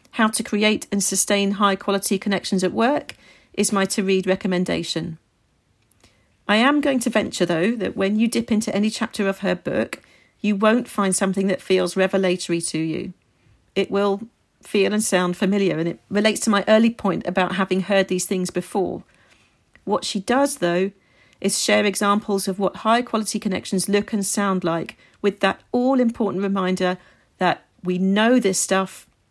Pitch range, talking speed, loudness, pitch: 185-210 Hz, 175 wpm, -21 LUFS, 195 Hz